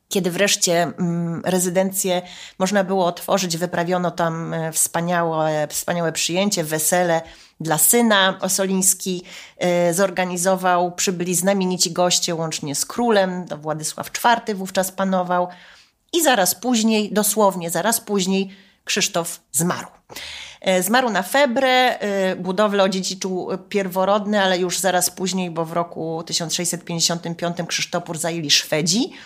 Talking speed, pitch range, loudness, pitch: 105 wpm, 170-195 Hz, -20 LUFS, 180 Hz